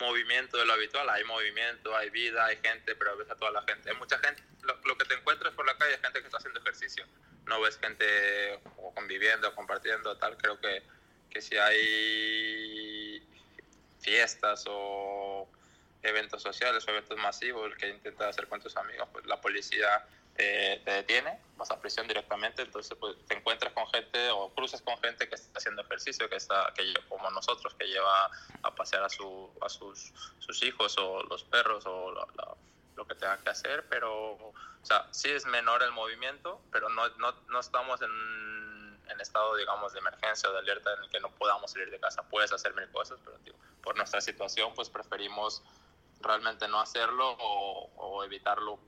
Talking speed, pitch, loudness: 190 wpm, 110 Hz, -31 LUFS